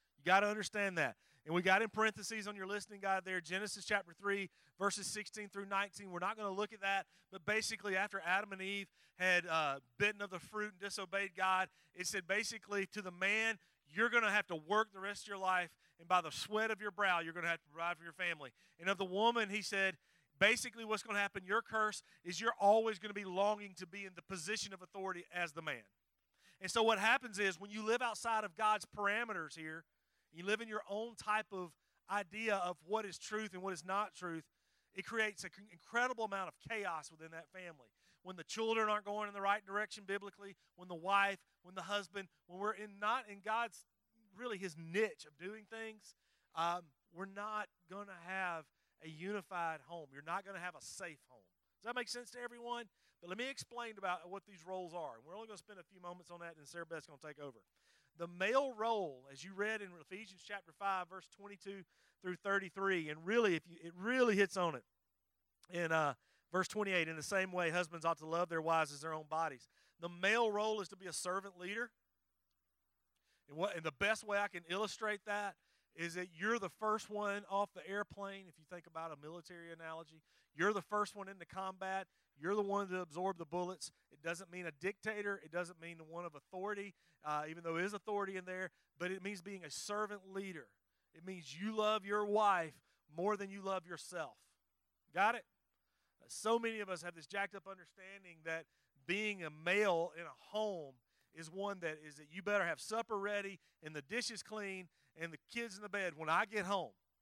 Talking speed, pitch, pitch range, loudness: 215 wpm, 195 Hz, 170-210 Hz, -40 LUFS